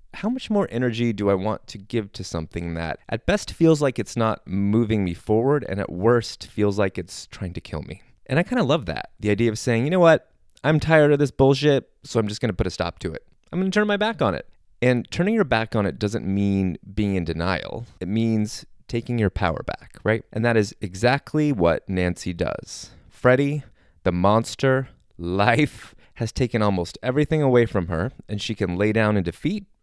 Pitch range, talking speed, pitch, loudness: 95-130 Hz, 215 wpm, 110 Hz, -23 LUFS